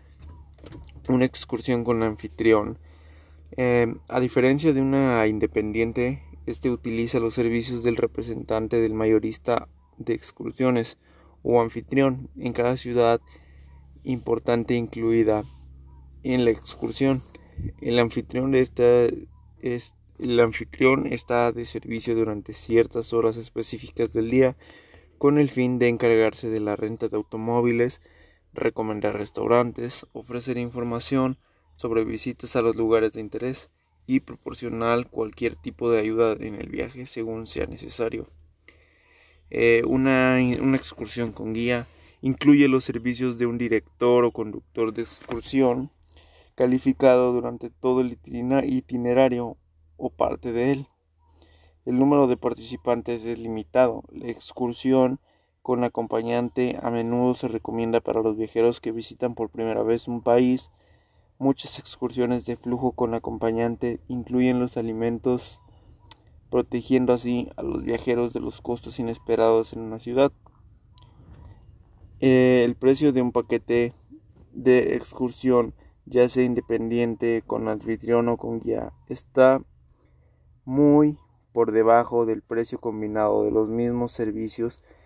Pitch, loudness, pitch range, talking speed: 120 Hz, -24 LUFS, 110-125 Hz, 125 wpm